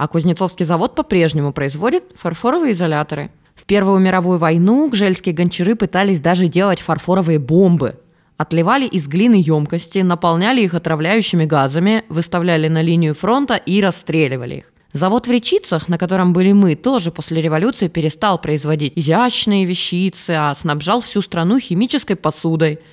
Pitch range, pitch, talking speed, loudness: 160-200 Hz, 175 Hz, 140 wpm, -16 LUFS